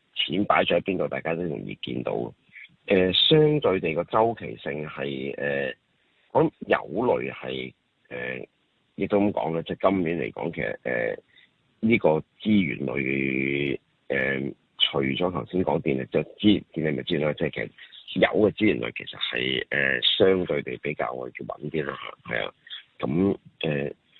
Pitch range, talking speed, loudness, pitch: 65-95 Hz, 260 characters per minute, -25 LUFS, 75 Hz